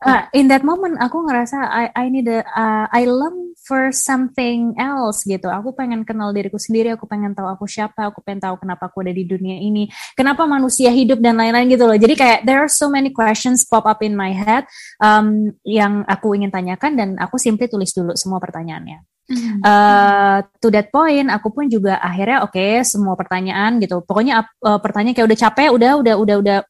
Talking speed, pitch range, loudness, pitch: 205 wpm, 200-255 Hz, -15 LUFS, 220 Hz